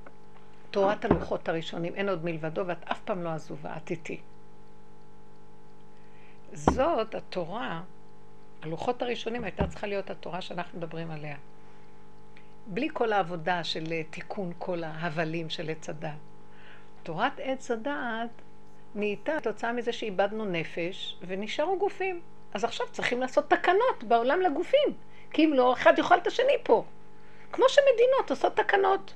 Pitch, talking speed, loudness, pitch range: 215 Hz, 130 wpm, -29 LUFS, 175-270 Hz